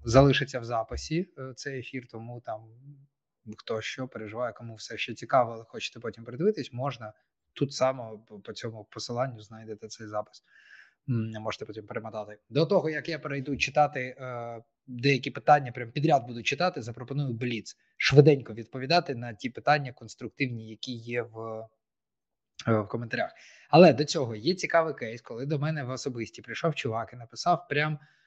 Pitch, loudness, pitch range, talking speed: 125 Hz, -28 LUFS, 115-145 Hz, 155 wpm